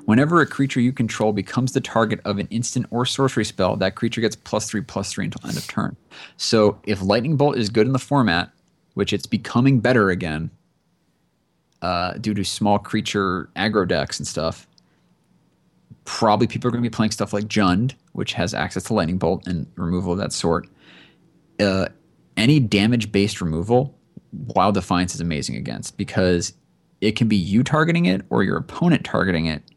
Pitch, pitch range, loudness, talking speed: 105 Hz, 95-120 Hz, -21 LUFS, 185 wpm